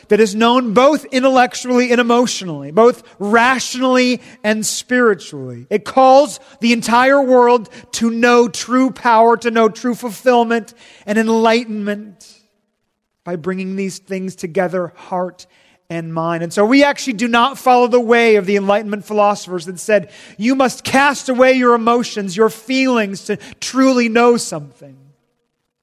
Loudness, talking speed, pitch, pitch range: -14 LUFS, 140 wpm, 225 Hz, 200-245 Hz